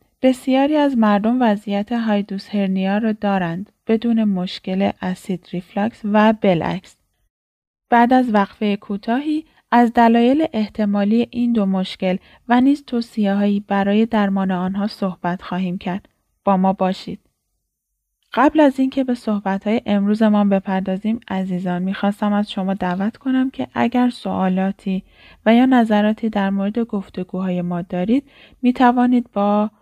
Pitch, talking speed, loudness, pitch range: 205 Hz, 125 wpm, -19 LUFS, 190-235 Hz